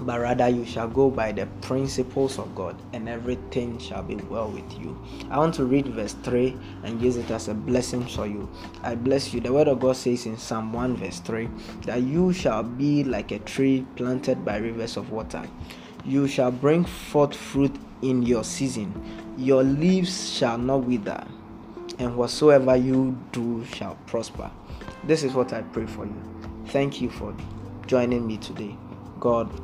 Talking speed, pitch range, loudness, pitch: 180 wpm, 110-130 Hz, -25 LUFS, 125 Hz